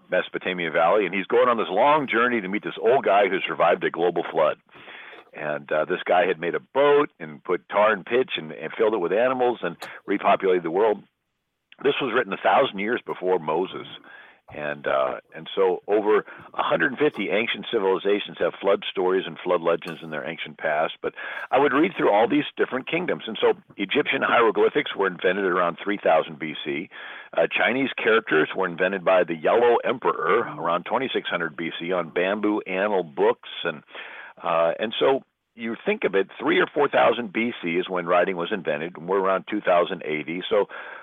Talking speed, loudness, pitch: 185 wpm, -23 LUFS, 130 Hz